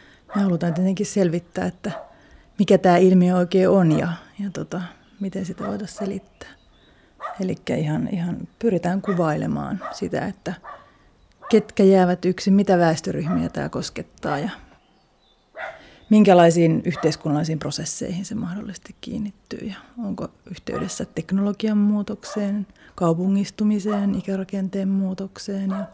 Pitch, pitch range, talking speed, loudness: 195 Hz, 180-205 Hz, 110 wpm, -22 LUFS